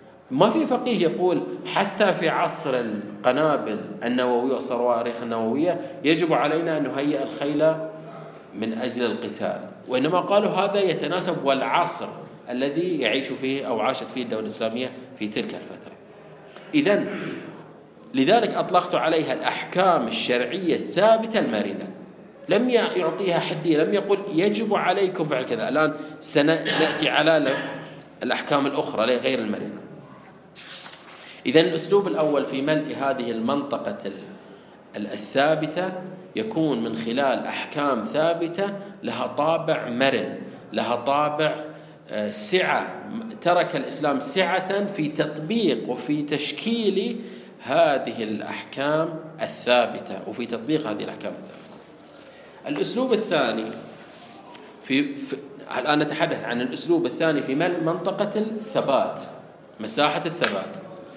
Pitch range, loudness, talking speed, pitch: 135-190 Hz, -24 LUFS, 105 wpm, 160 Hz